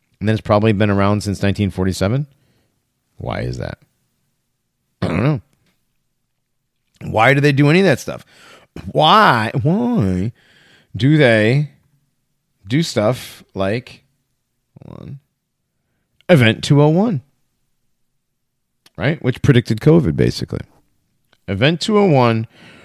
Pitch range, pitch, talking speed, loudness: 105-145 Hz, 125 Hz, 100 wpm, -16 LUFS